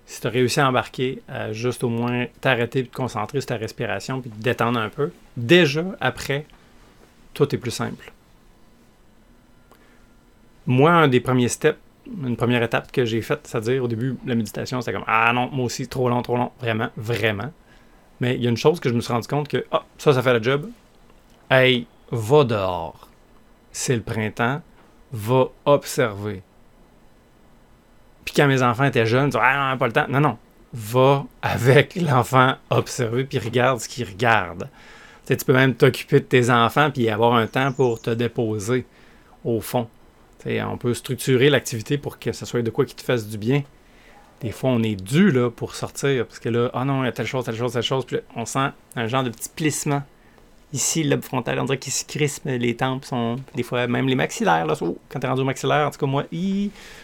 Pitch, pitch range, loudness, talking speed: 125 Hz, 115-135 Hz, -22 LUFS, 220 wpm